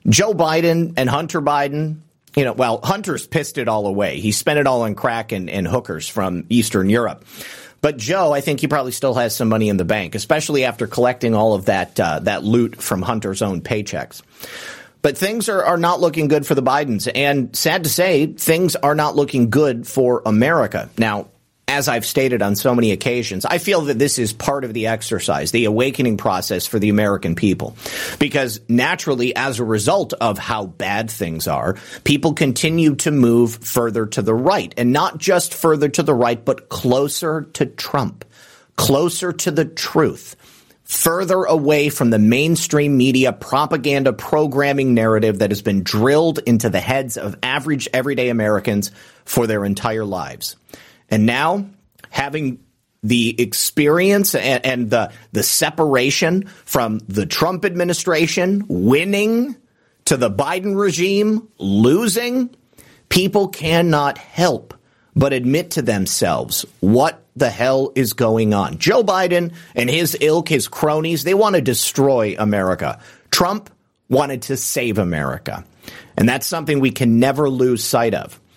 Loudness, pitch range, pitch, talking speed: -18 LUFS, 115-155 Hz, 130 Hz, 160 wpm